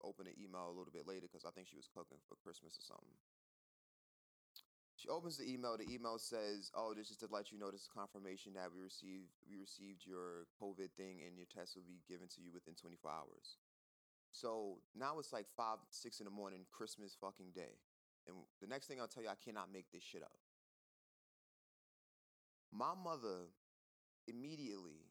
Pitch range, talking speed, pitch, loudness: 90-100 Hz, 195 wpm, 95 Hz, -52 LUFS